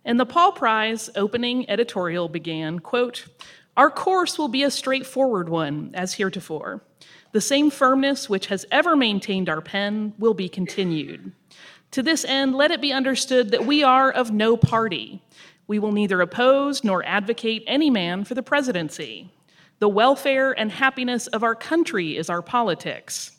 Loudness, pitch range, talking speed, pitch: -21 LUFS, 190-265 Hz, 160 wpm, 225 Hz